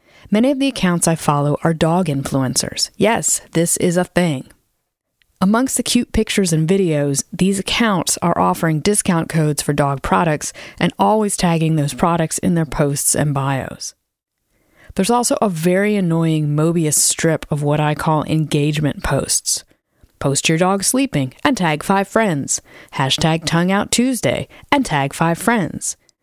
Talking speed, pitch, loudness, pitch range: 155 wpm, 165 Hz, -17 LUFS, 150-195 Hz